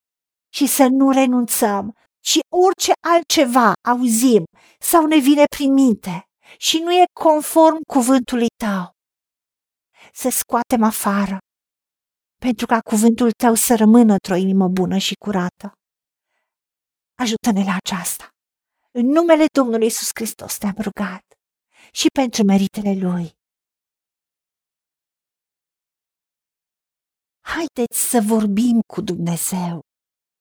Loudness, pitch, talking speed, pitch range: -17 LUFS, 235 Hz, 105 wpm, 200-270 Hz